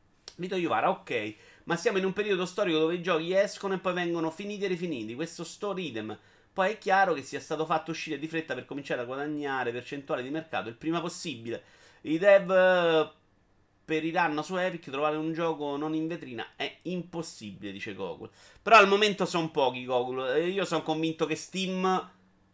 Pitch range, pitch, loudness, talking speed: 140-185 Hz, 160 Hz, -29 LUFS, 185 wpm